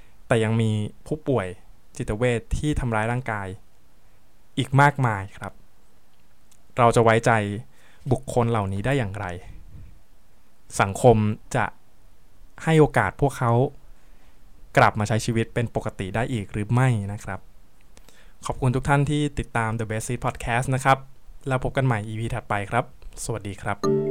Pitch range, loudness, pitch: 105-130 Hz, -24 LUFS, 115 Hz